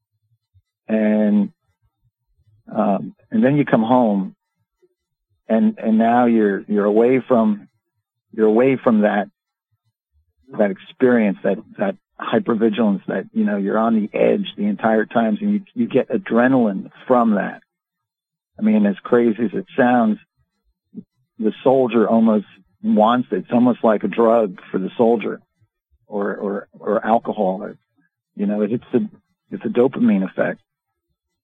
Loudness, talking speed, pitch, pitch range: -18 LUFS, 140 wpm, 115 Hz, 110-165 Hz